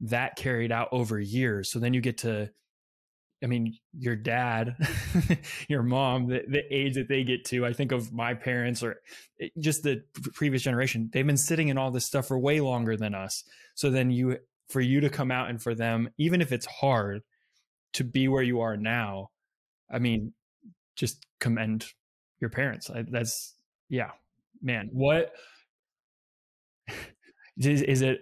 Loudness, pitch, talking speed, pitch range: -29 LUFS, 125 Hz, 170 wpm, 115-135 Hz